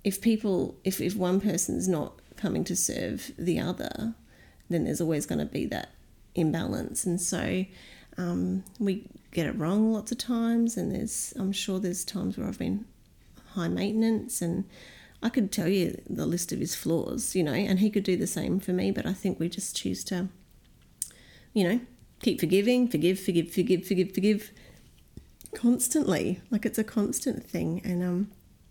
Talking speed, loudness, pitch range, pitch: 175 wpm, -29 LUFS, 180-225 Hz, 195 Hz